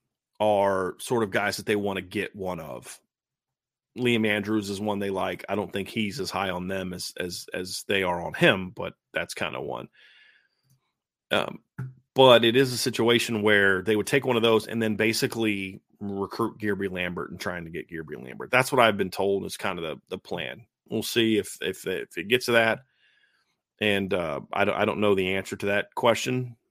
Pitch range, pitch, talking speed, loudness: 100-115 Hz, 105 Hz, 210 wpm, -25 LUFS